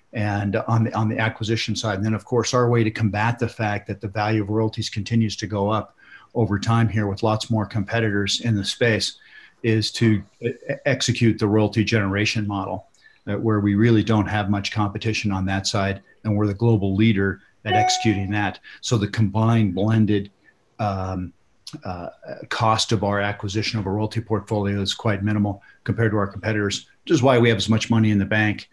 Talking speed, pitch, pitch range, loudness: 195 wpm, 110 Hz, 100-110 Hz, -22 LUFS